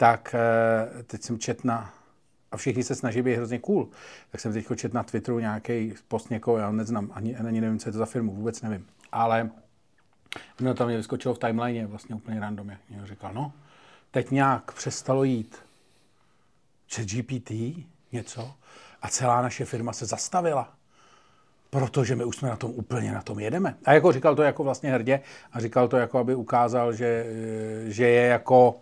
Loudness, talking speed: -26 LUFS, 180 wpm